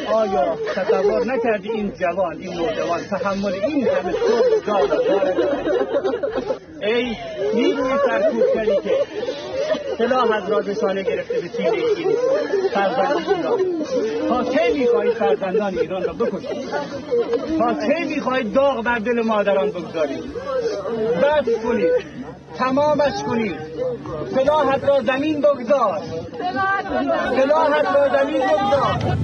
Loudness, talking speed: -20 LUFS, 105 wpm